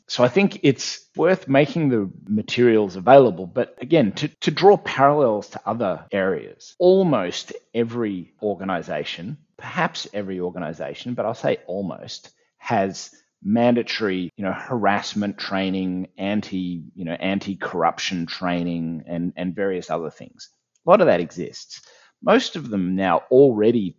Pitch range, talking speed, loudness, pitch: 90-135 Hz, 135 wpm, -21 LUFS, 105 Hz